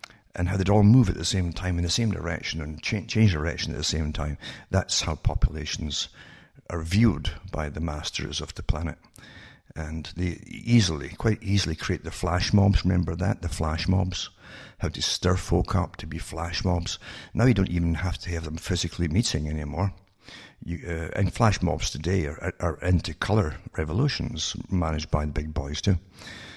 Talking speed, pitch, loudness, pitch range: 190 wpm, 85 Hz, -26 LUFS, 80-95 Hz